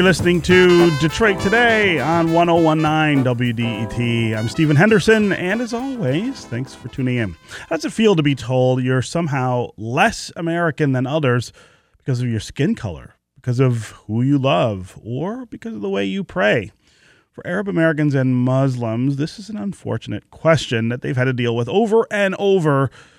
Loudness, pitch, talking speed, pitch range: -18 LUFS, 140 Hz, 175 wpm, 120-175 Hz